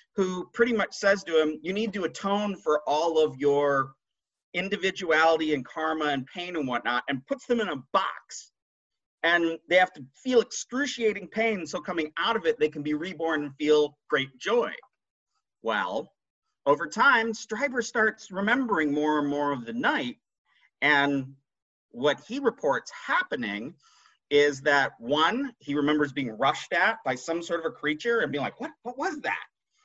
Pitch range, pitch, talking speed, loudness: 150-230 Hz, 170 Hz, 170 wpm, -27 LUFS